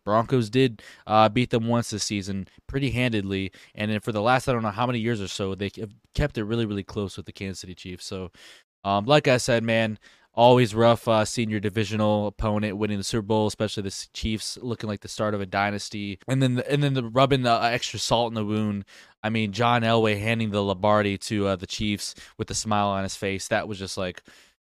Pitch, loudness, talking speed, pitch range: 110 Hz, -25 LUFS, 230 wpm, 100-115 Hz